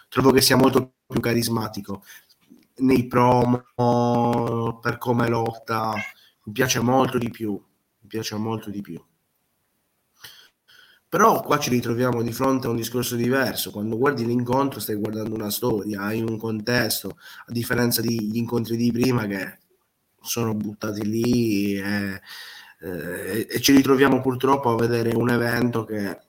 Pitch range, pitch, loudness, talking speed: 110-125 Hz, 115 Hz, -22 LUFS, 145 wpm